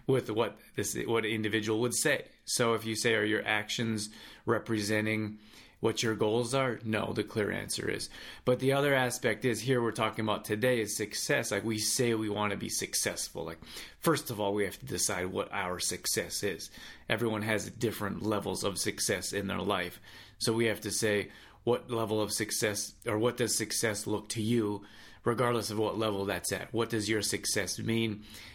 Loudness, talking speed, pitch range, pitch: -31 LUFS, 195 wpm, 105-115 Hz, 110 Hz